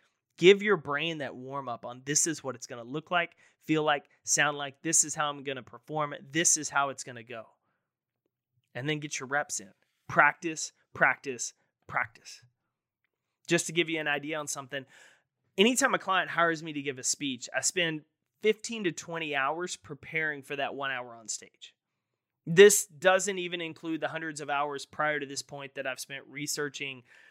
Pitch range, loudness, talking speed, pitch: 135-165 Hz, -29 LUFS, 190 wpm, 150 Hz